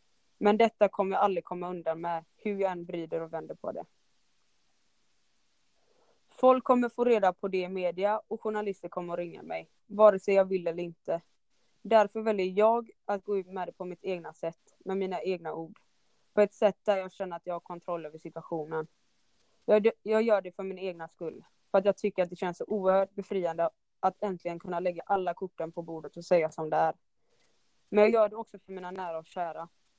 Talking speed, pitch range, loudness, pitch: 210 wpm, 170-205 Hz, -30 LUFS, 185 Hz